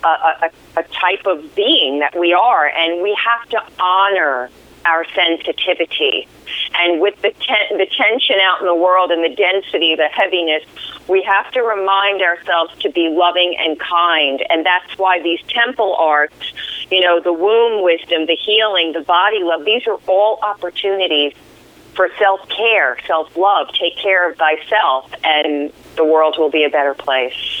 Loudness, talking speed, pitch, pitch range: -15 LUFS, 170 wpm, 180 Hz, 165-200 Hz